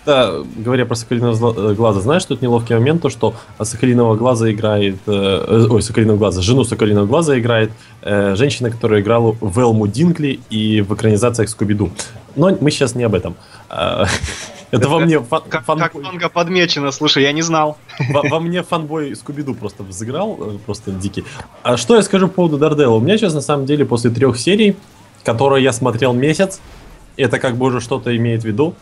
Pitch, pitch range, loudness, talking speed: 125 Hz, 110-150 Hz, -15 LUFS, 175 wpm